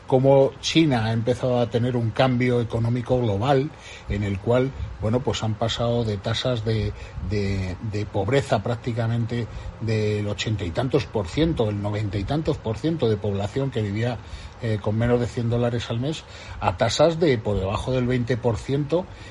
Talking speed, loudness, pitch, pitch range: 175 wpm, -24 LUFS, 115 Hz, 105-125 Hz